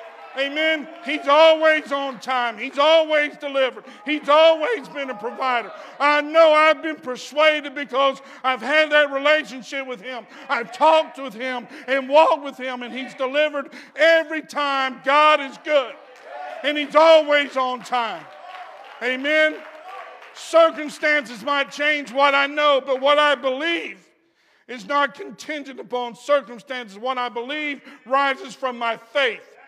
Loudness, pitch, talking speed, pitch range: -19 LUFS, 280 Hz, 140 wpm, 260-305 Hz